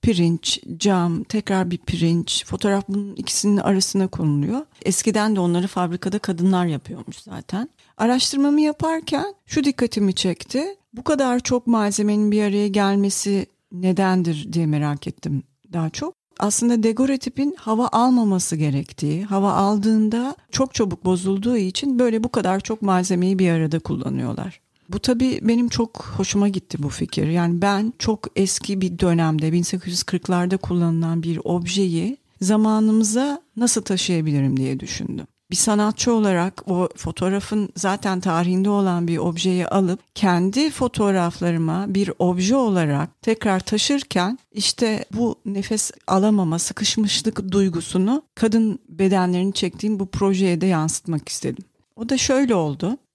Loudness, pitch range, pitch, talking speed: -21 LUFS, 180-225 Hz, 195 Hz, 130 wpm